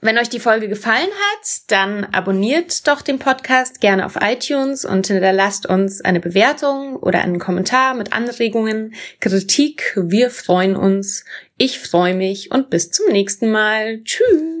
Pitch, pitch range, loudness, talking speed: 215 Hz, 190-260 Hz, -16 LUFS, 150 wpm